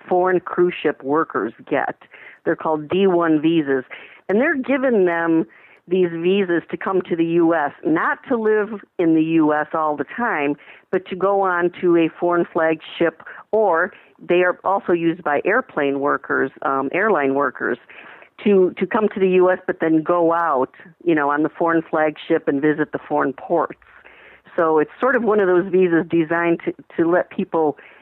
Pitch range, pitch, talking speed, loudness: 160-190 Hz, 170 Hz, 175 wpm, -19 LUFS